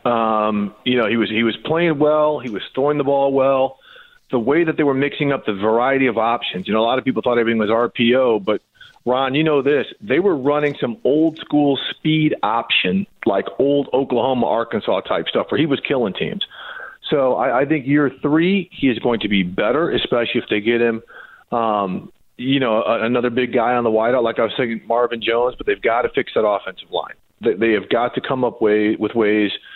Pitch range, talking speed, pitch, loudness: 115-145 Hz, 225 wpm, 125 Hz, -18 LUFS